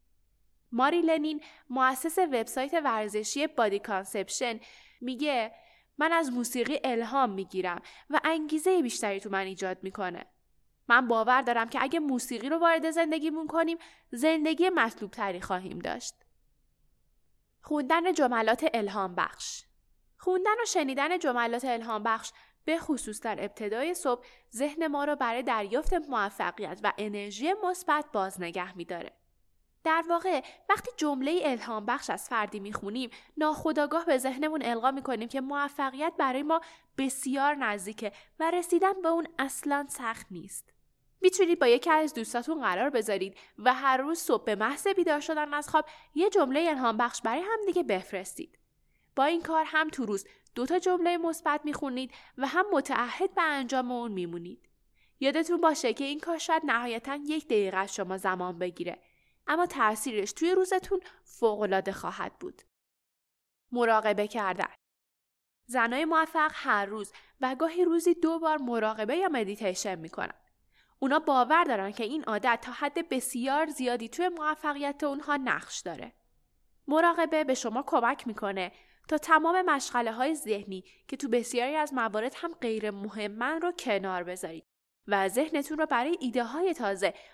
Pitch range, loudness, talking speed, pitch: 220-320 Hz, -29 LUFS, 145 wpm, 265 Hz